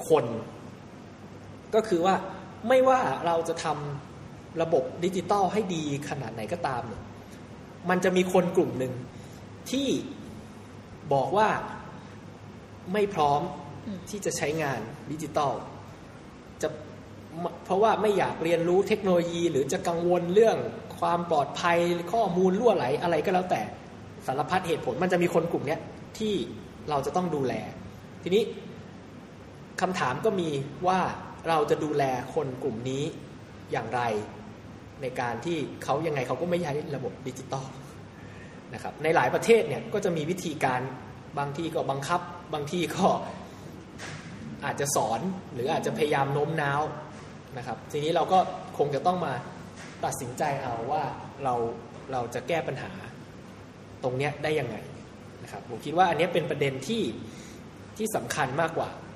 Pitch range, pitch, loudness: 130-180 Hz, 155 Hz, -28 LUFS